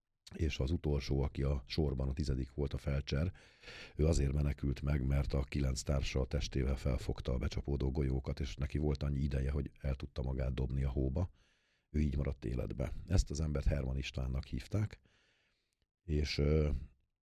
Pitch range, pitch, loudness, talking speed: 65-75 Hz, 70 Hz, -37 LUFS, 165 wpm